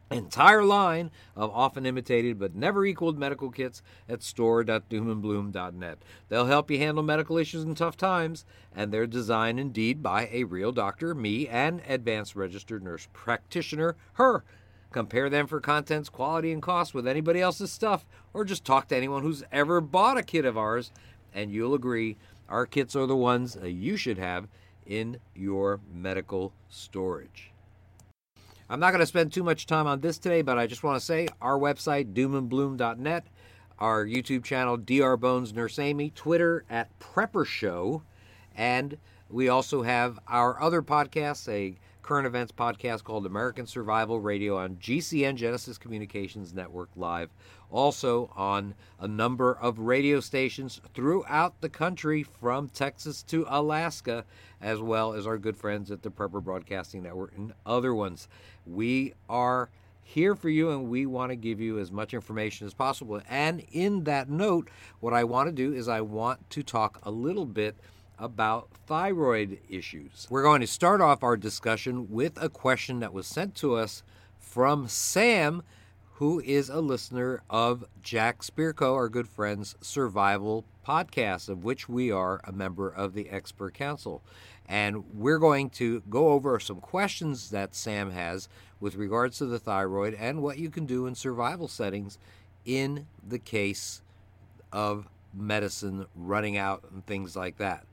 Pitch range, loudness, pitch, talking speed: 100-140 Hz, -28 LUFS, 115 Hz, 160 wpm